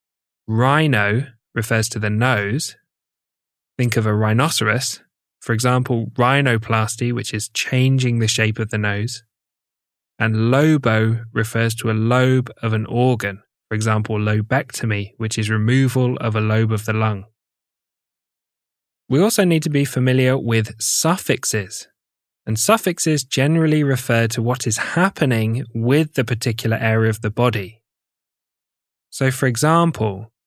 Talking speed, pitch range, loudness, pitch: 130 wpm, 110-130 Hz, -19 LUFS, 115 Hz